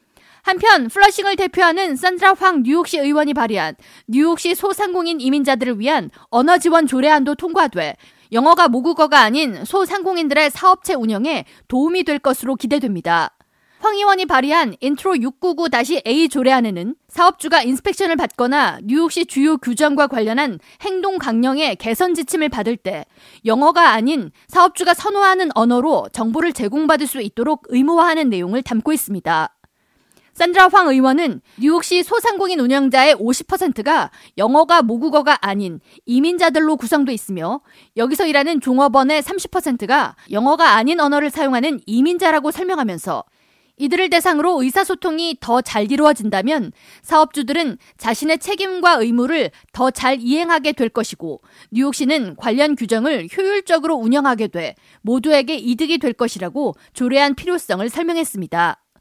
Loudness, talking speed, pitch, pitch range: -16 LUFS, 340 characters per minute, 290 Hz, 245-335 Hz